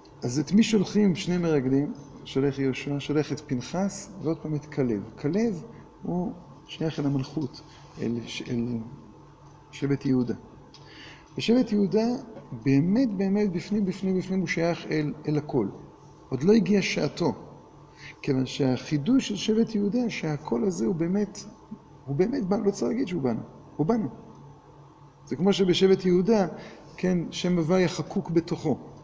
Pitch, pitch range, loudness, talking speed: 160 Hz, 145-195 Hz, -27 LUFS, 140 wpm